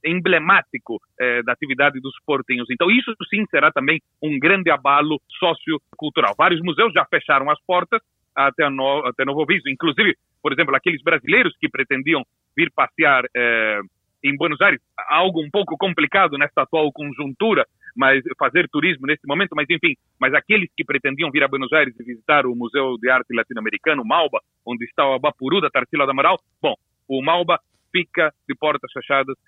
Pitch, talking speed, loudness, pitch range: 150 Hz, 175 wpm, -19 LUFS, 135-170 Hz